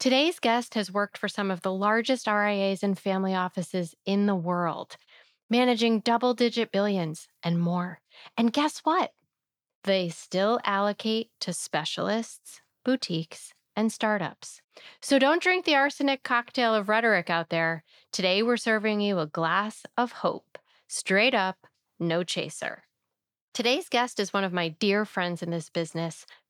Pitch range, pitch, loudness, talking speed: 180-235 Hz, 205 Hz, -27 LUFS, 150 wpm